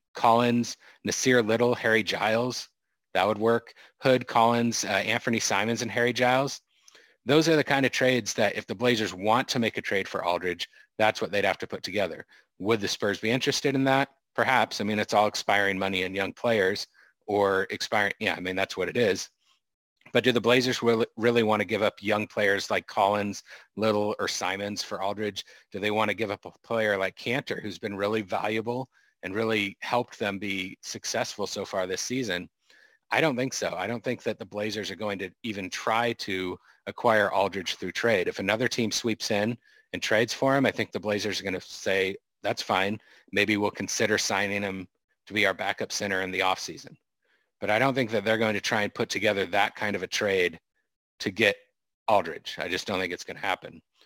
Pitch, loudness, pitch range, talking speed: 110 Hz, -27 LUFS, 100-120 Hz, 210 wpm